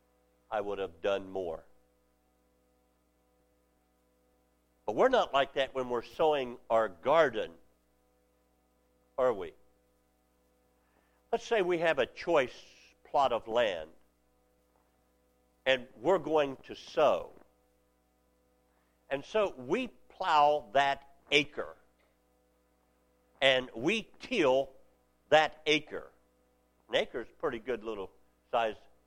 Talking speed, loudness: 100 wpm, -31 LUFS